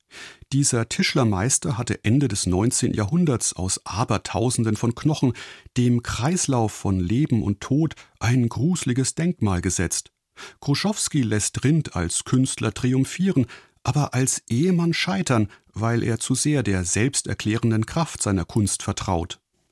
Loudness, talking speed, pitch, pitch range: -23 LUFS, 125 wpm, 120 Hz, 105-140 Hz